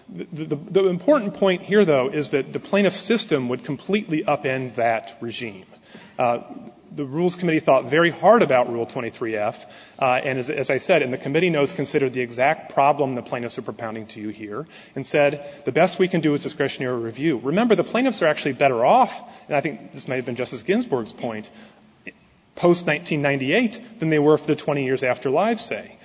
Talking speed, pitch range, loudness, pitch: 200 wpm, 130-175 Hz, -21 LUFS, 145 Hz